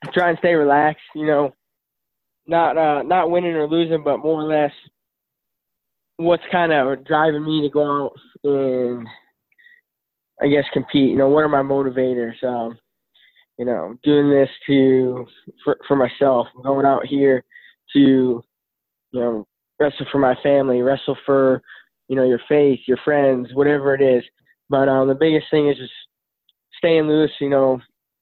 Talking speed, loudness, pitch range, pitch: 160 wpm, -18 LUFS, 130-155 Hz, 140 Hz